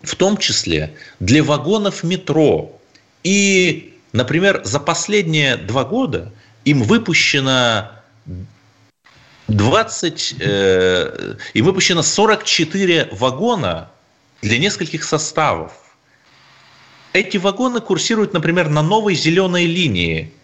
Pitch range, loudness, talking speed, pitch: 115-190 Hz, -16 LUFS, 90 wpm, 160 Hz